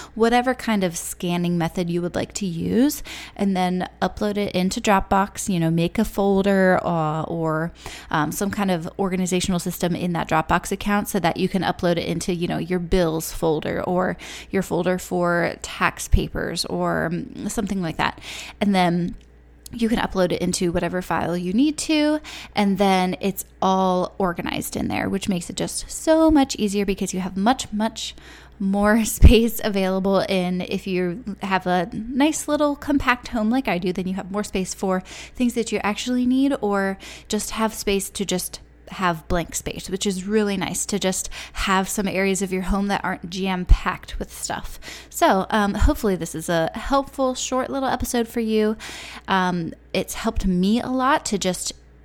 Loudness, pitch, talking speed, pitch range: -22 LUFS, 195 Hz, 185 wpm, 180-215 Hz